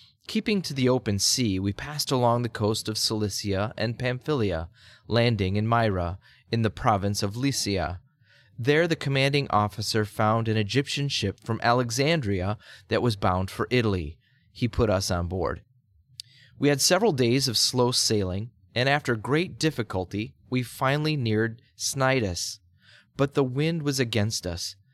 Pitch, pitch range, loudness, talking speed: 115 Hz, 105-130 Hz, -25 LUFS, 150 wpm